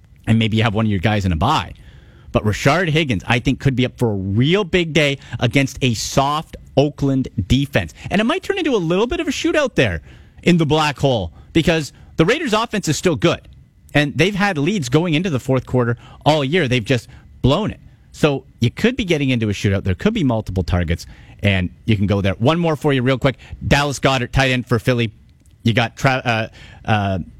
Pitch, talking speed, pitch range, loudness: 130 Hz, 220 wpm, 110-155 Hz, -18 LUFS